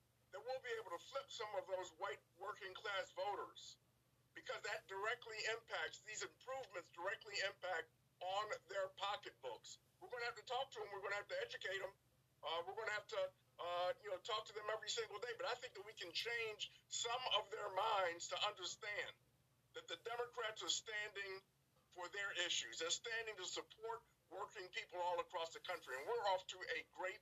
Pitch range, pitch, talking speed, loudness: 185-270 Hz, 215 Hz, 200 wpm, -46 LUFS